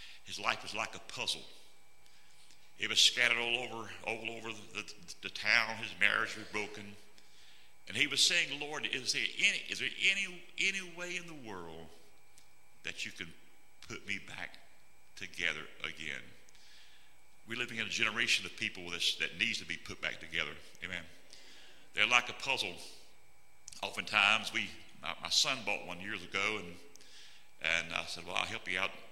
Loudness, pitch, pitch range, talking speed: -33 LUFS, 110 Hz, 100-120 Hz, 170 wpm